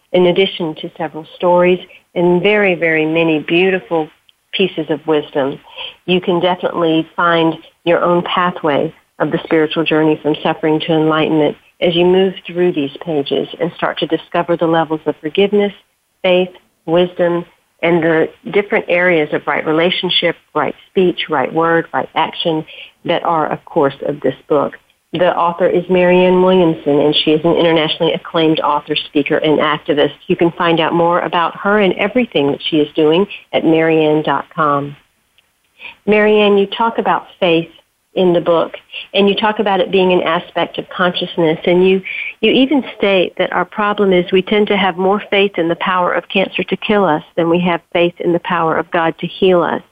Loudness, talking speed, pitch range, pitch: -14 LUFS, 175 wpm, 160-185 Hz, 170 Hz